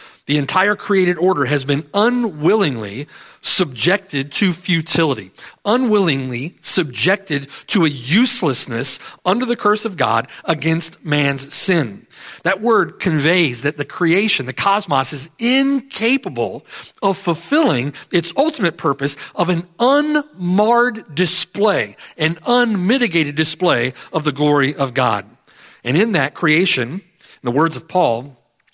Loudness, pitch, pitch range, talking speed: -17 LUFS, 175 Hz, 145-205 Hz, 125 wpm